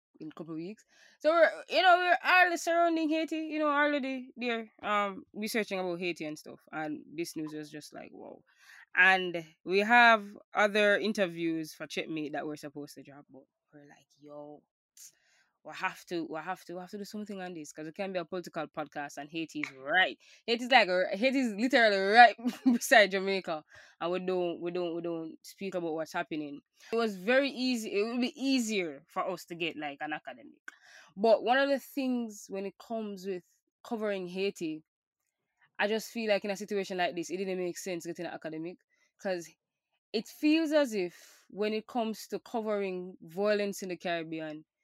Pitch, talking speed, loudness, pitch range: 195 Hz, 200 wpm, -30 LUFS, 165-235 Hz